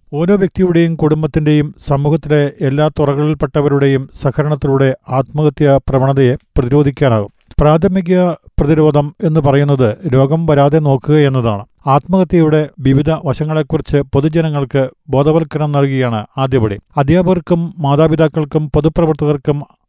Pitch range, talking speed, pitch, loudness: 140-160 Hz, 85 wpm, 150 Hz, -13 LUFS